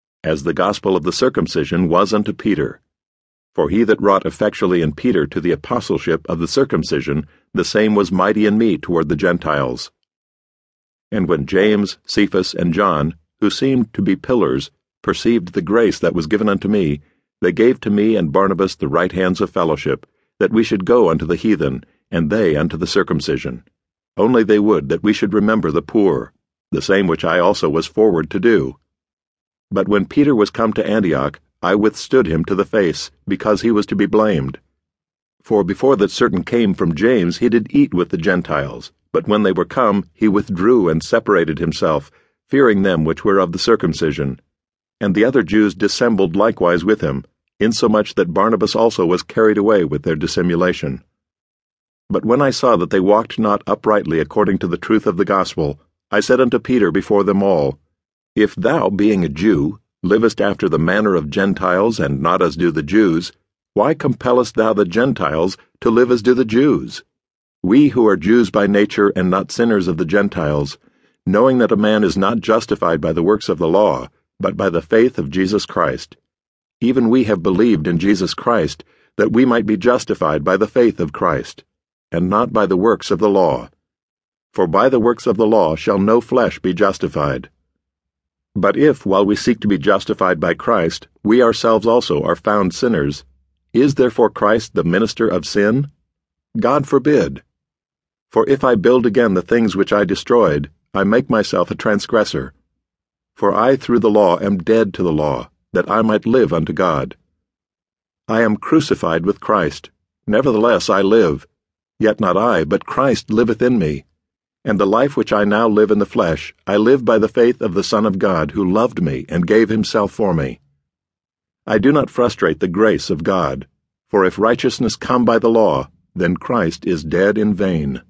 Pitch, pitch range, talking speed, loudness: 100 Hz, 85-110 Hz, 185 wpm, -16 LUFS